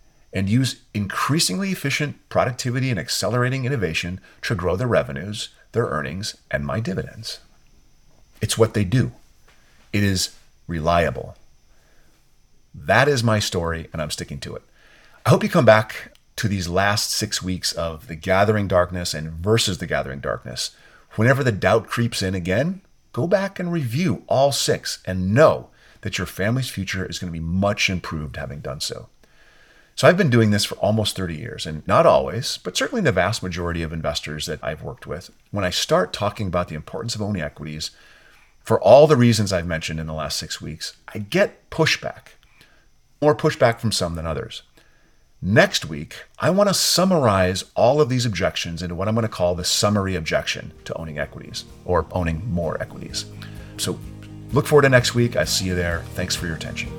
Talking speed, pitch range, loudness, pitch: 180 wpm, 90-125 Hz, -21 LUFS, 105 Hz